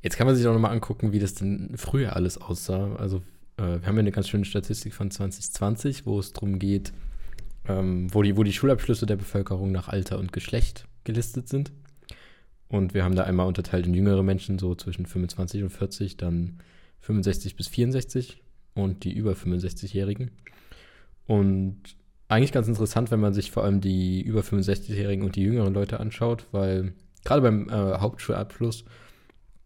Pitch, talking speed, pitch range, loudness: 100 Hz, 175 wpm, 95-110 Hz, -26 LUFS